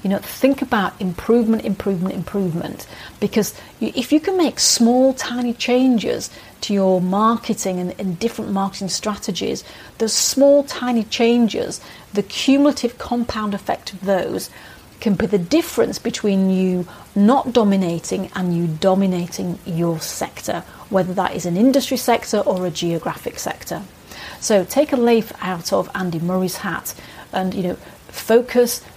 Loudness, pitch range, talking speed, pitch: -19 LUFS, 185-240 Hz, 140 wpm, 205 Hz